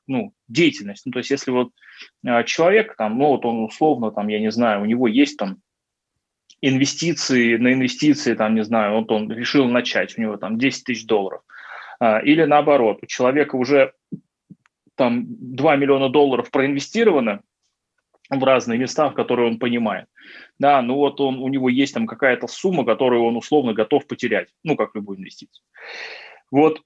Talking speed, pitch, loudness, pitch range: 170 wpm, 130 Hz, -19 LUFS, 115-145 Hz